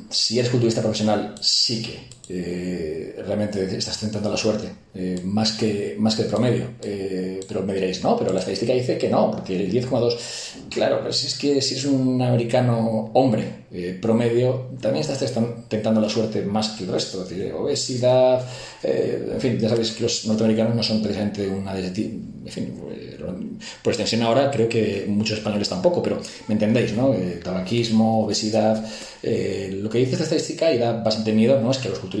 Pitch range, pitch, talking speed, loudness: 105-120 Hz, 110 Hz, 190 wpm, -22 LUFS